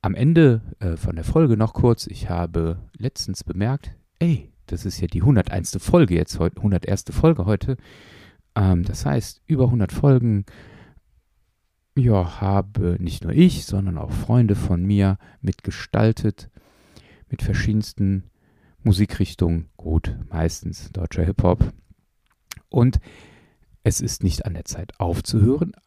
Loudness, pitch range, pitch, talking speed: -21 LUFS, 90-115 Hz, 100 Hz, 125 wpm